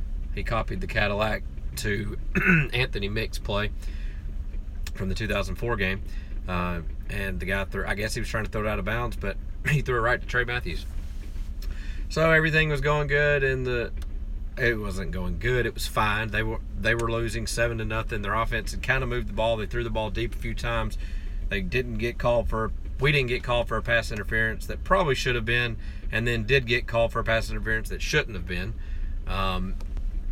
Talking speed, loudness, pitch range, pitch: 215 wpm, -27 LUFS, 90-120 Hz, 110 Hz